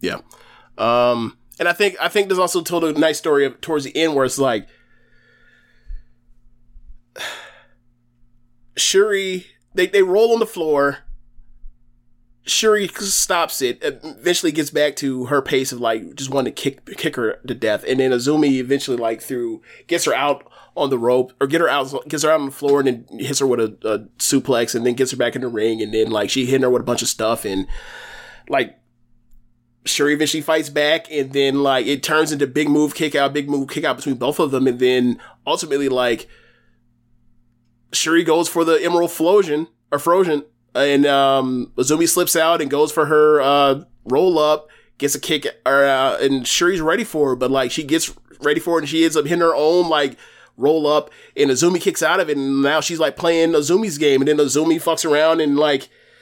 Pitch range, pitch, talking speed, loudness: 125-160 Hz, 140 Hz, 200 wpm, -18 LUFS